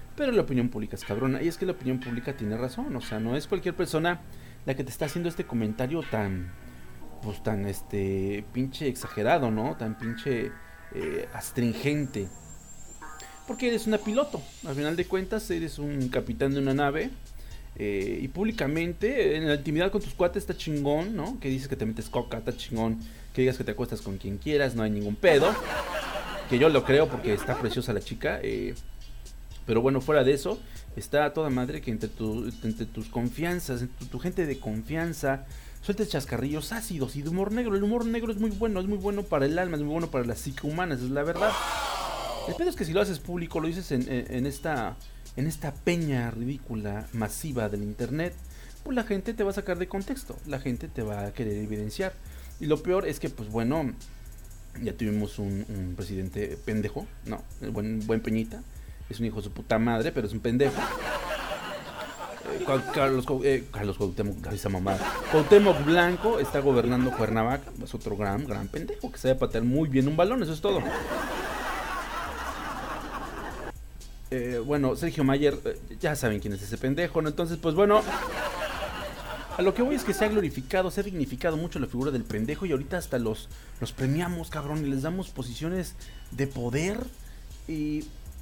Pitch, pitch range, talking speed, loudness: 135 Hz, 110-170 Hz, 190 wpm, -29 LUFS